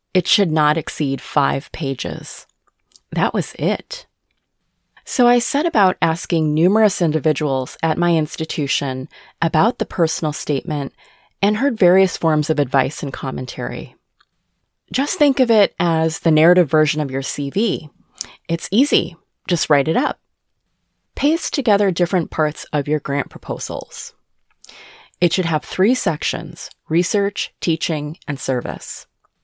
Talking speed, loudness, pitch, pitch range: 135 wpm, -19 LUFS, 165 Hz, 150-195 Hz